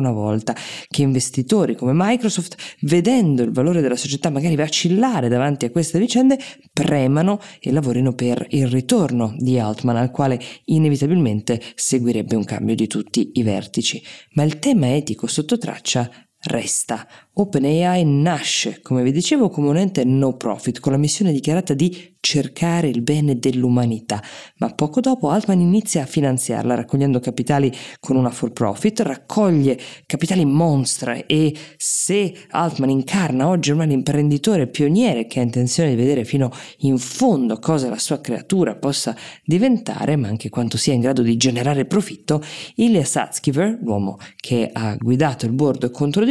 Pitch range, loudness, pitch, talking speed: 125-170 Hz, -19 LUFS, 145 Hz, 150 wpm